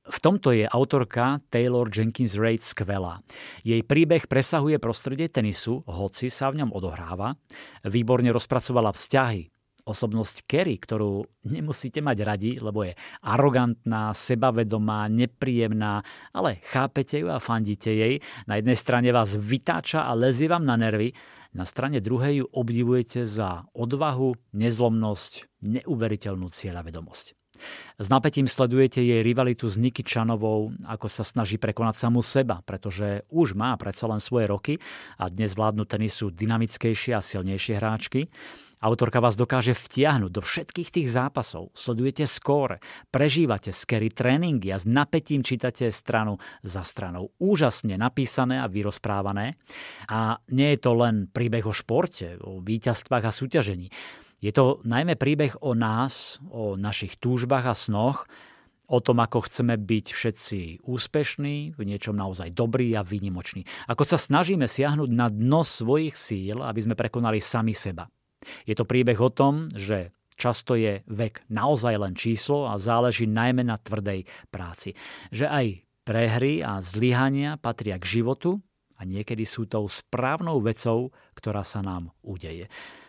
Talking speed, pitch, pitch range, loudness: 140 wpm, 115 Hz, 105-130 Hz, -25 LUFS